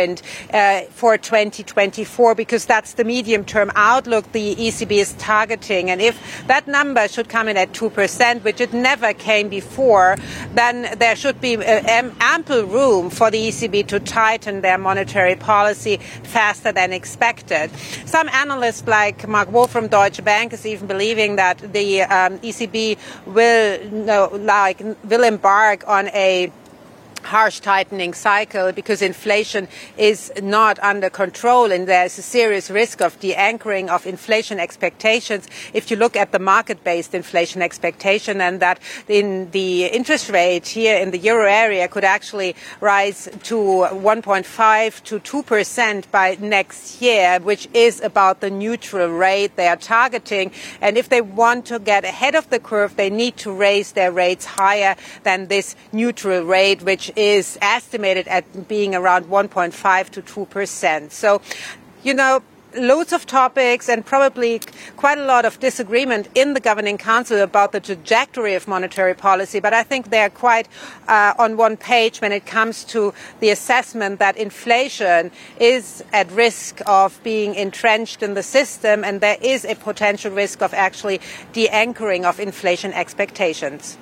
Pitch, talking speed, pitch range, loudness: 210 Hz, 160 wpm, 195-230 Hz, -17 LUFS